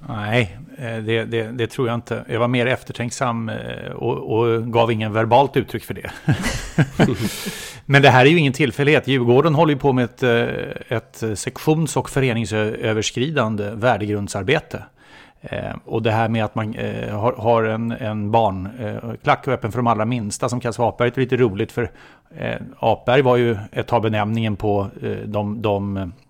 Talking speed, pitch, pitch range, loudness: 155 wpm, 115 Hz, 110-125 Hz, -20 LUFS